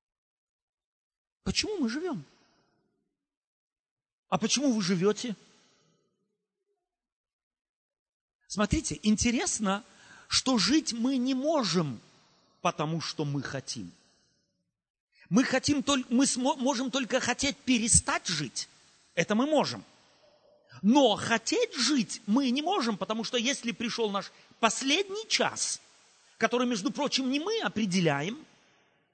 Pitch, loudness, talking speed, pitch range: 240 Hz, -28 LUFS, 100 wpm, 205-275 Hz